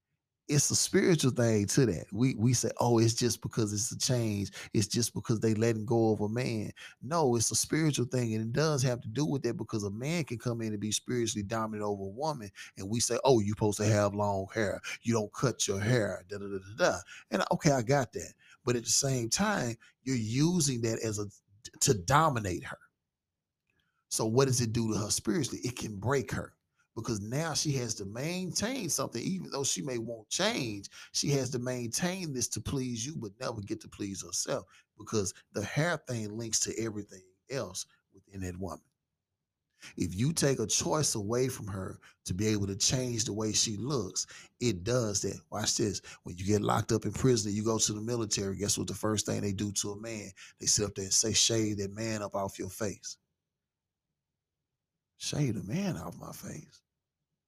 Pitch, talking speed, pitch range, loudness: 115 Hz, 210 wpm, 105-130 Hz, -31 LUFS